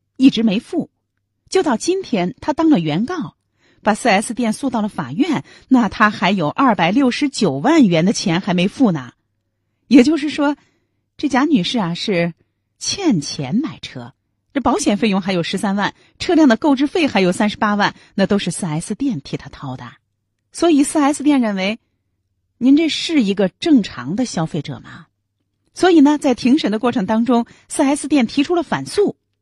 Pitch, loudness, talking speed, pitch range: 220 Hz, -17 LUFS, 250 characters per minute, 170-280 Hz